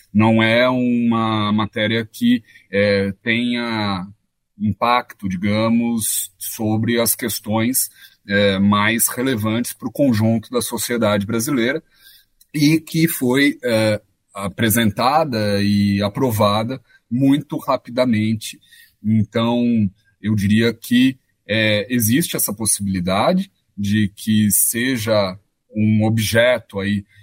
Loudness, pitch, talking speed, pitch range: -18 LUFS, 110 Hz, 95 wpm, 105-120 Hz